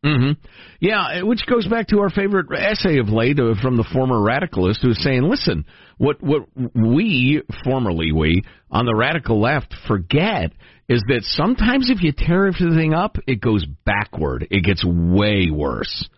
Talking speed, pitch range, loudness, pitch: 165 wpm, 105-170 Hz, -19 LUFS, 130 Hz